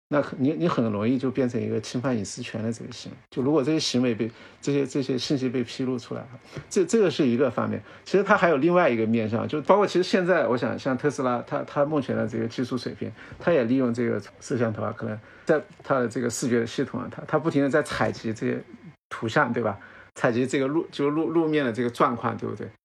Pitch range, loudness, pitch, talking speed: 115-145 Hz, -25 LUFS, 125 Hz, 360 characters per minute